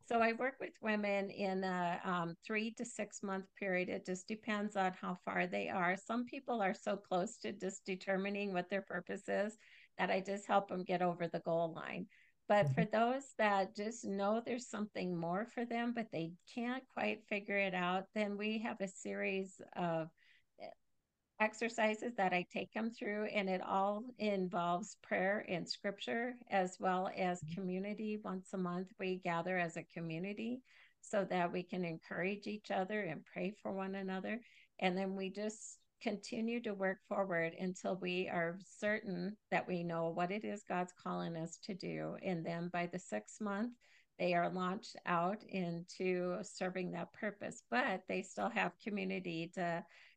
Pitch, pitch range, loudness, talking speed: 190 Hz, 180-210 Hz, -40 LUFS, 175 wpm